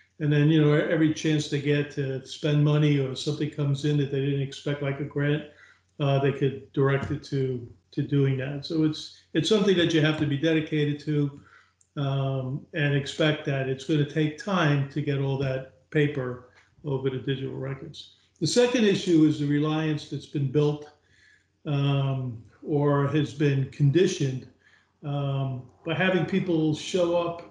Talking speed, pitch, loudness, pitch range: 175 wpm, 145 Hz, -26 LUFS, 135-155 Hz